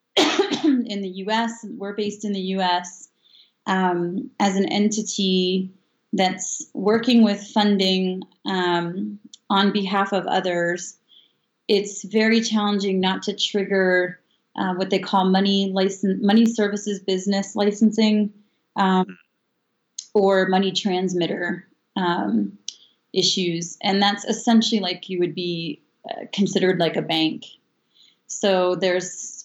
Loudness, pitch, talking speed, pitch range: -21 LUFS, 195 Hz, 115 wpm, 185-210 Hz